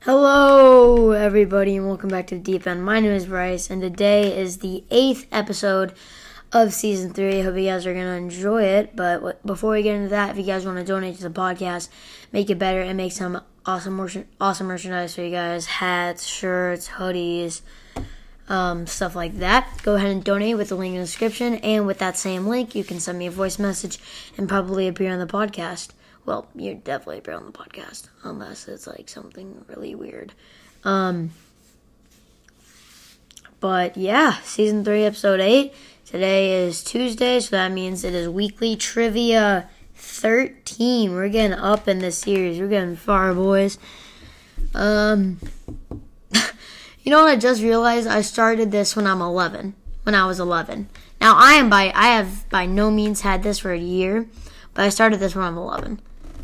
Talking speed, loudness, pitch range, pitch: 185 wpm, -20 LUFS, 185-210 Hz, 195 Hz